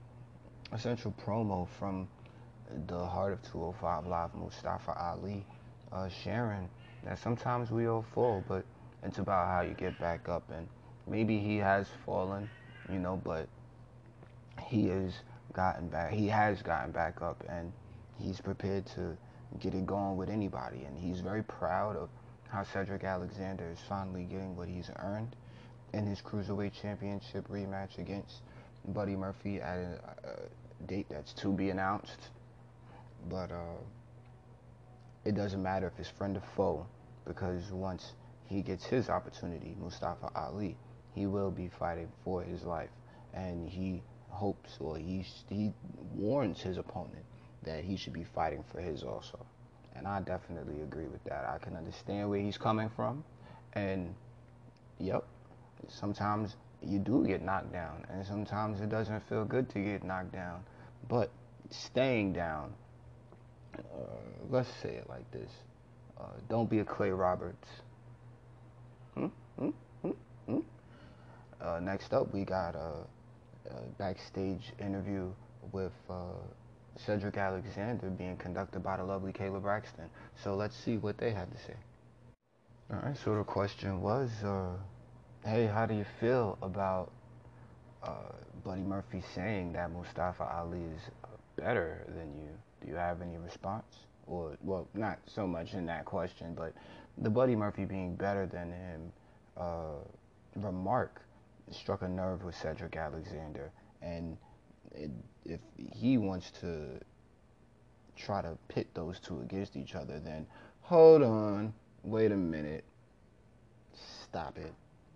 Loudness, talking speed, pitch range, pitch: -37 LUFS, 145 wpm, 95-120 Hz, 100 Hz